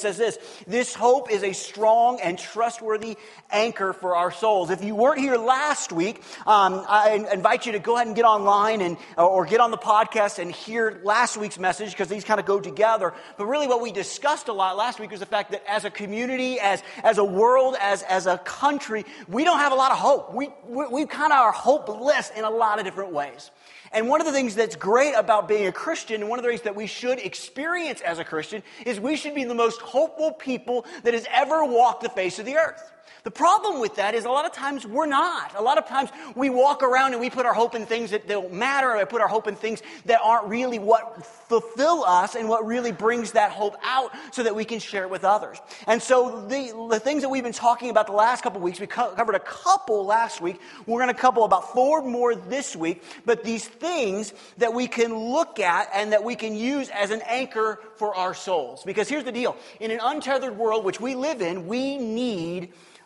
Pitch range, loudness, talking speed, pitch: 205-255 Hz, -23 LUFS, 245 wpm, 230 Hz